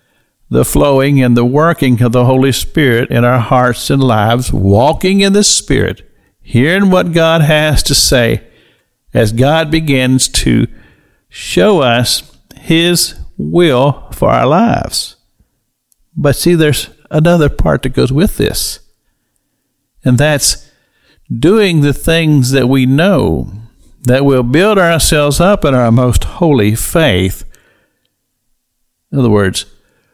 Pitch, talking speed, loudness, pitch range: 135 Hz, 130 wpm, -10 LUFS, 120-160 Hz